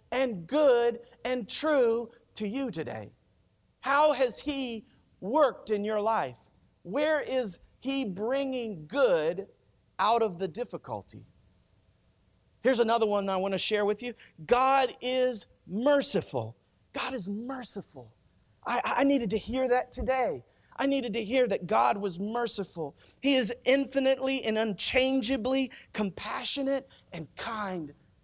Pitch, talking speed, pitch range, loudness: 230 Hz, 130 wpm, 185-260 Hz, -29 LUFS